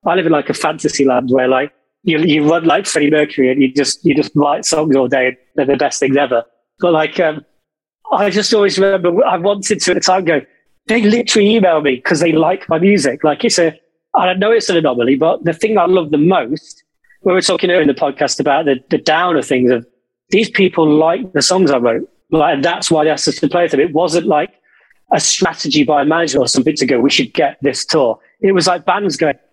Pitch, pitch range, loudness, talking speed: 165 Hz, 145-185 Hz, -13 LUFS, 250 wpm